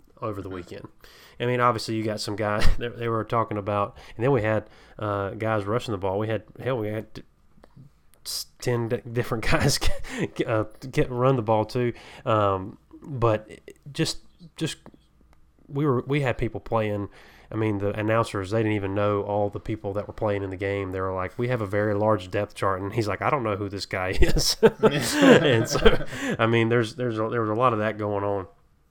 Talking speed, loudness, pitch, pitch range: 210 wpm, -25 LUFS, 110 Hz, 100-120 Hz